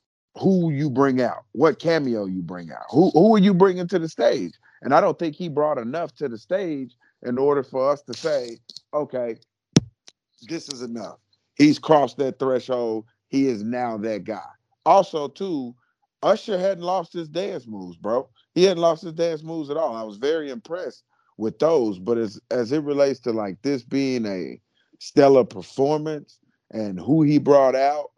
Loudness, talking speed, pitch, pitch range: -22 LUFS, 185 wpm, 140 Hz, 115-160 Hz